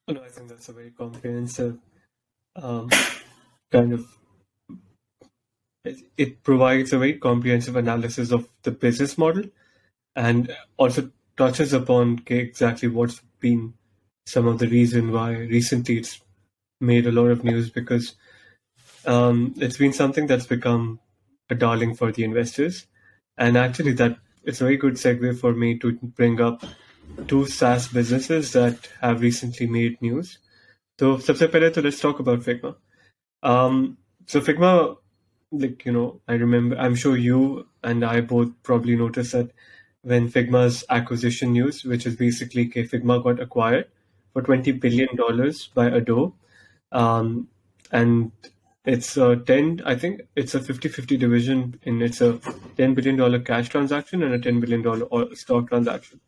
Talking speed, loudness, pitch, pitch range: 150 wpm, -22 LUFS, 120 Hz, 120-130 Hz